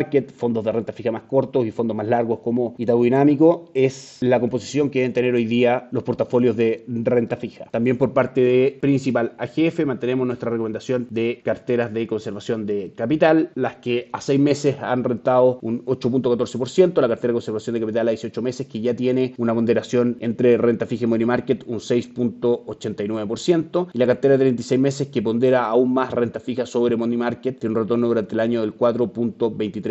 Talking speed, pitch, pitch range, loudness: 190 wpm, 120 Hz, 115-130 Hz, -21 LUFS